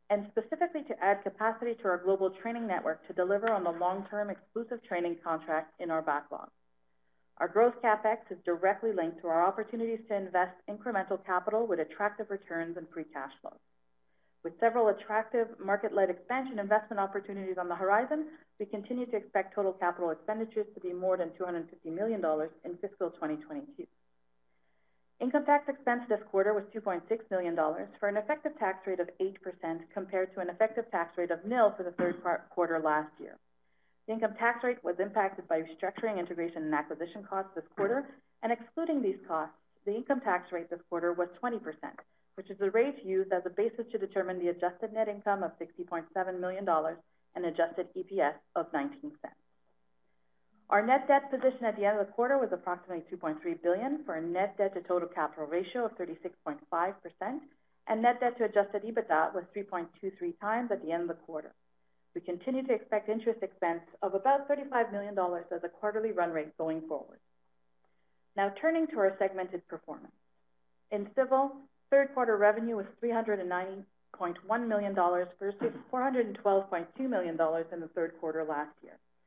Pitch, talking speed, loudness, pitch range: 190 Hz, 175 wpm, -33 LUFS, 170-220 Hz